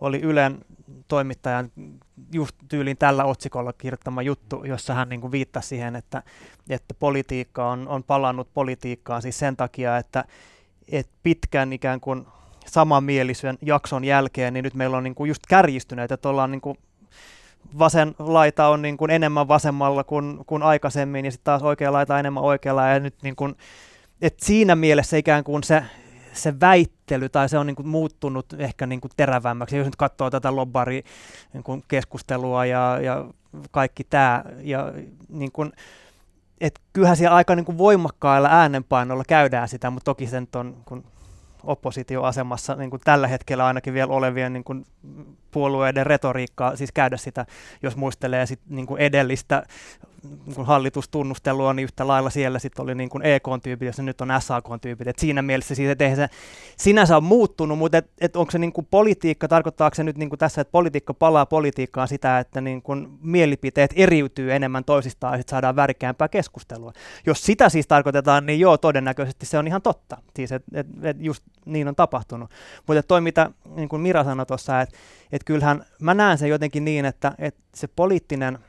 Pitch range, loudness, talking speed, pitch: 130-150 Hz, -21 LUFS, 160 wpm, 135 Hz